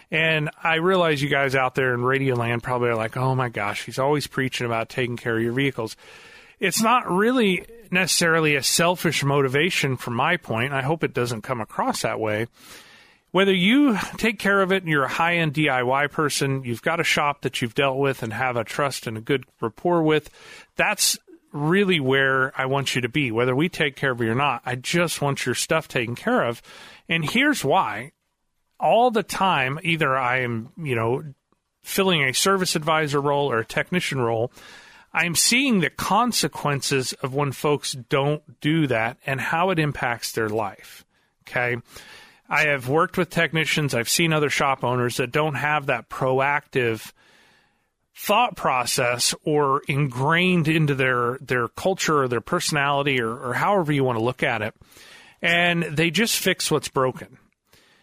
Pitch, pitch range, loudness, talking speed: 145 Hz, 130-165 Hz, -22 LUFS, 180 wpm